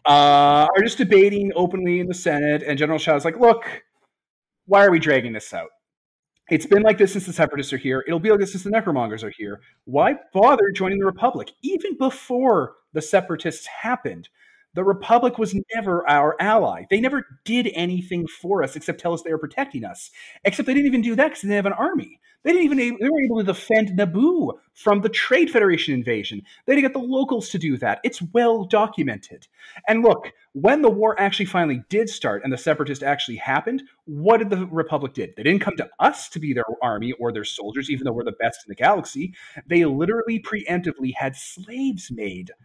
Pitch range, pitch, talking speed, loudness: 155-230 Hz, 195 Hz, 210 wpm, -20 LUFS